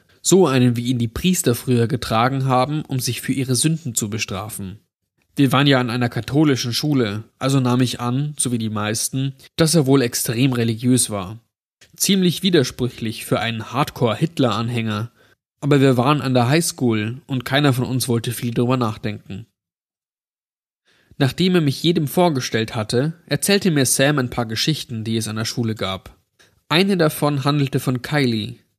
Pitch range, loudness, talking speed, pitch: 115-145 Hz, -19 LUFS, 165 wpm, 125 Hz